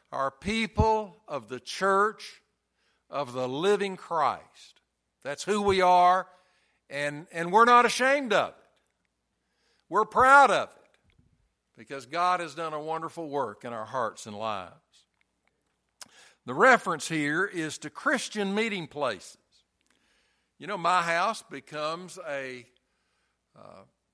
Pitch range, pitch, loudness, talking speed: 140-205 Hz, 170 Hz, -26 LUFS, 125 wpm